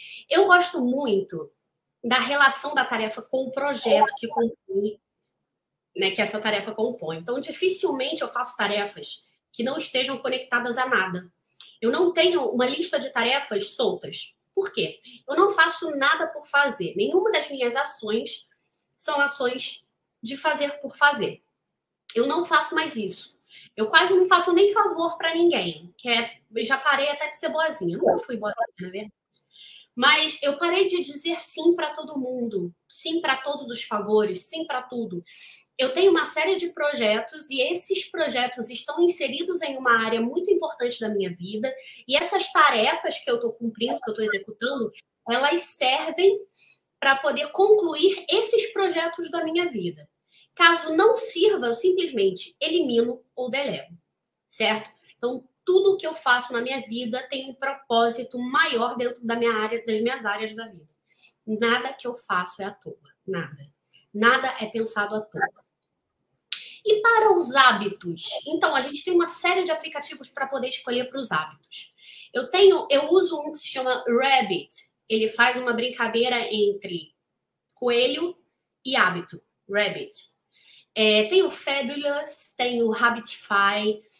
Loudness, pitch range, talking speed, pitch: -23 LUFS, 230-325 Hz, 160 wpm, 265 Hz